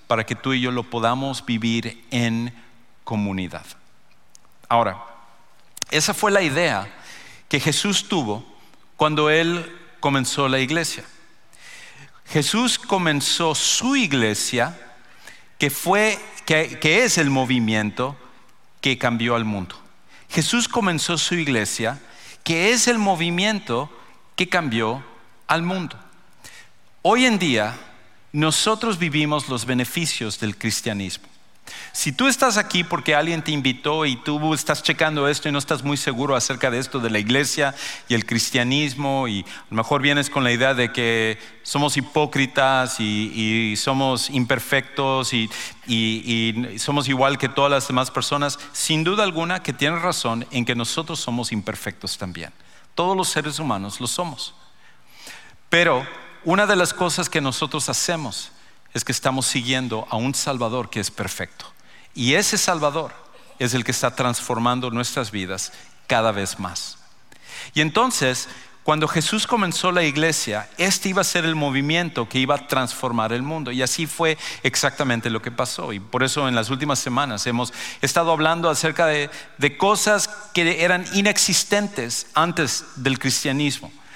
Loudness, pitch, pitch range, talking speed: -21 LUFS, 135 Hz, 120-160 Hz, 150 wpm